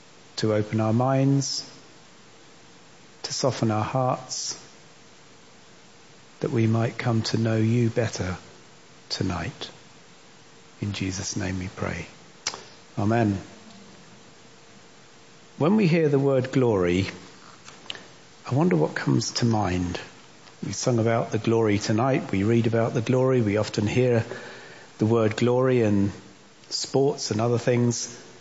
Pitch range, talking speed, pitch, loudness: 105-130 Hz, 120 wpm, 115 Hz, -24 LUFS